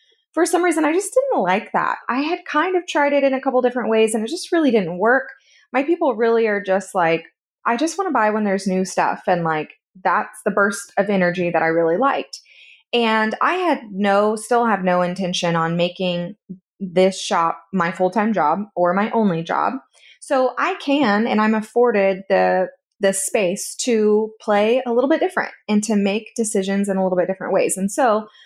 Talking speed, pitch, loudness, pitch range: 205 wpm, 210 Hz, -19 LUFS, 185-260 Hz